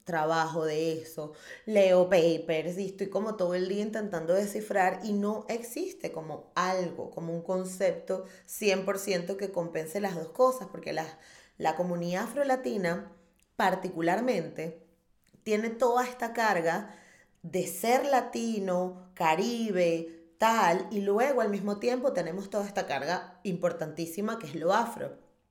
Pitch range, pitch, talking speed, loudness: 170-210 Hz, 185 Hz, 130 wpm, -30 LUFS